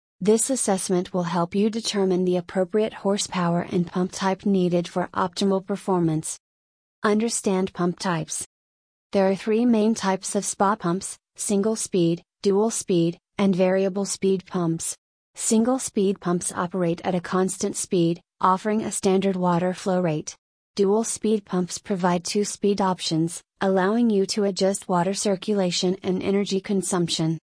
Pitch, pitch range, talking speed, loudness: 190 Hz, 180-205 Hz, 140 wpm, -23 LUFS